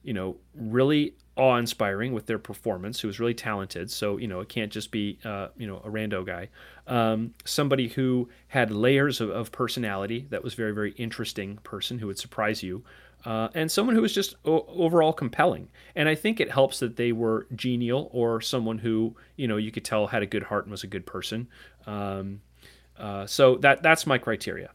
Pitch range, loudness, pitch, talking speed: 105-130 Hz, -27 LUFS, 115 Hz, 205 wpm